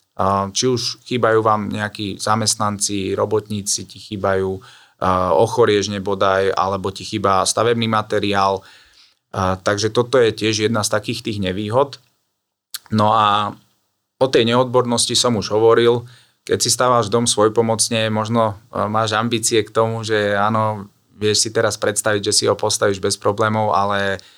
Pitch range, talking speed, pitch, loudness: 100-115 Hz, 140 wpm, 105 Hz, -18 LUFS